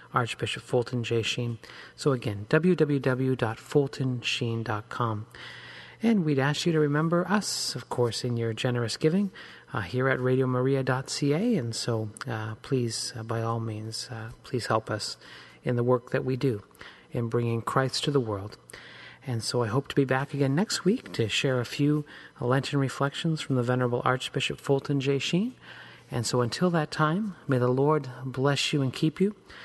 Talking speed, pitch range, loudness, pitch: 170 wpm, 120-145 Hz, -28 LUFS, 130 Hz